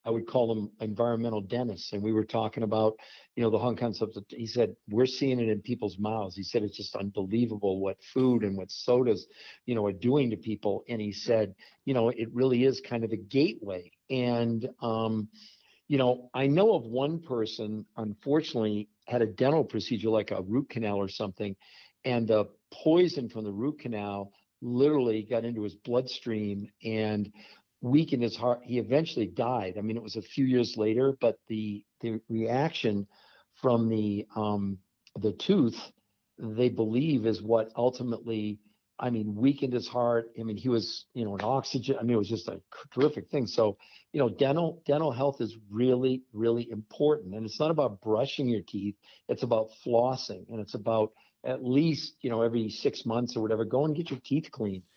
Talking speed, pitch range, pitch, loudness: 190 wpm, 105-125 Hz, 115 Hz, -30 LUFS